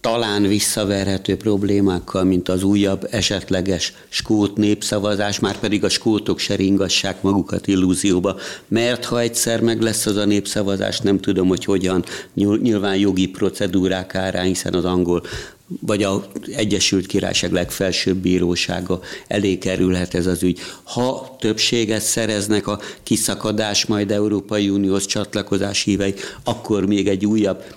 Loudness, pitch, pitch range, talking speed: -19 LUFS, 100 Hz, 95-105 Hz, 130 wpm